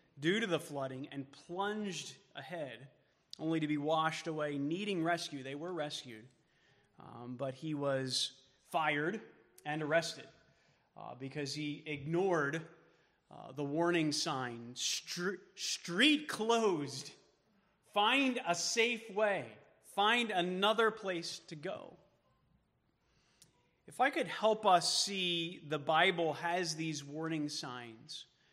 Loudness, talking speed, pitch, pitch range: -35 LUFS, 120 wpm, 160 Hz, 145-185 Hz